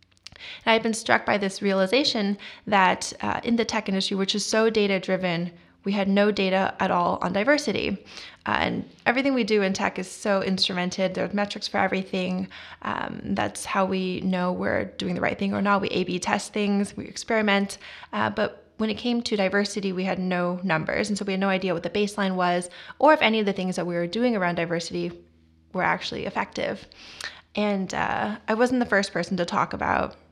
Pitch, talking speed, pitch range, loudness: 195 Hz, 210 wpm, 185-215 Hz, -25 LUFS